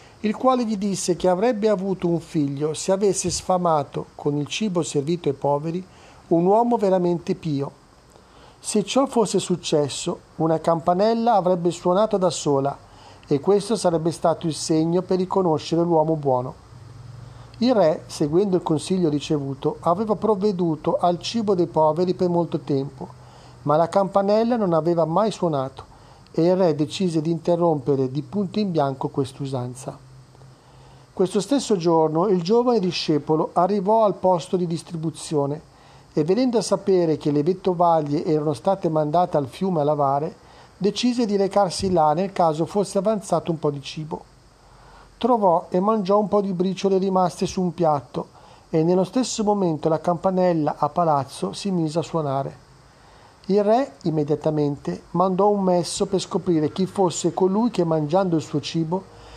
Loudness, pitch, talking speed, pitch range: -22 LUFS, 175 Hz, 155 wpm, 150-195 Hz